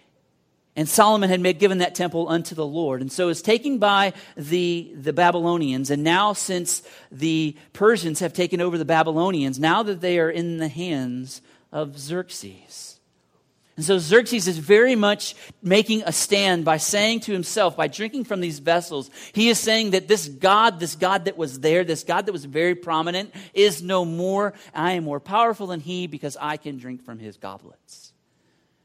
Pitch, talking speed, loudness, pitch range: 175 Hz, 185 wpm, -21 LUFS, 155-200 Hz